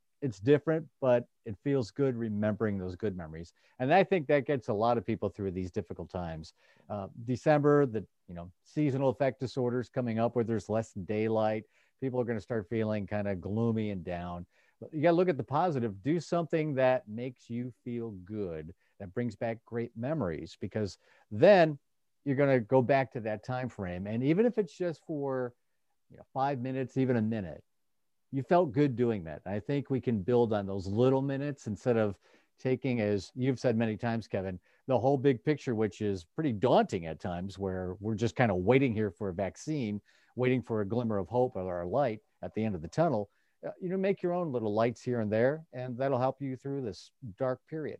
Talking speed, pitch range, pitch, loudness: 210 wpm, 105-135 Hz, 120 Hz, -31 LUFS